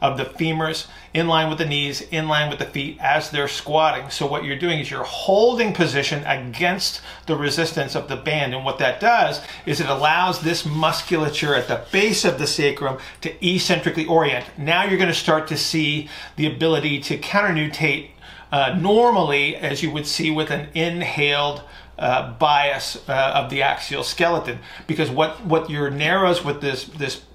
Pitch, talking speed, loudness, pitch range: 155 Hz, 185 wpm, -20 LUFS, 145-165 Hz